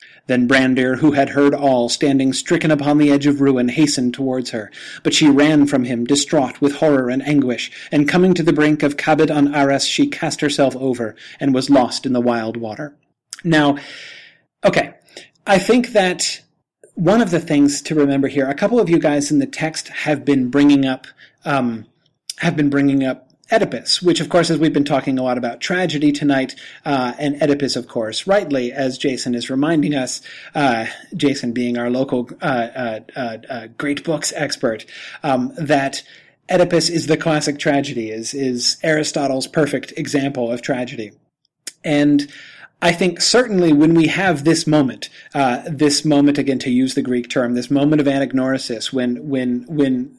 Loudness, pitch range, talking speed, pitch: -17 LUFS, 130-155 Hz, 180 wpm, 140 Hz